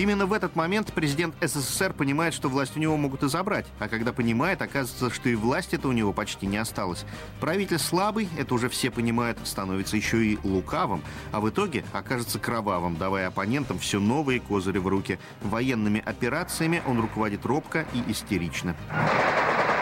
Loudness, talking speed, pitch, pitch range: -27 LUFS, 170 wpm, 120 Hz, 105-150 Hz